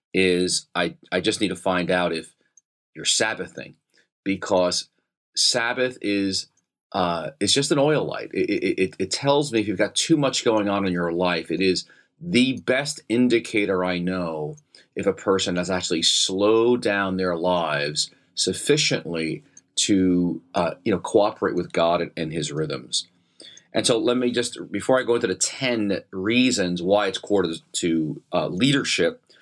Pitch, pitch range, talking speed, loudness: 95 Hz, 90-120 Hz, 165 wpm, -22 LUFS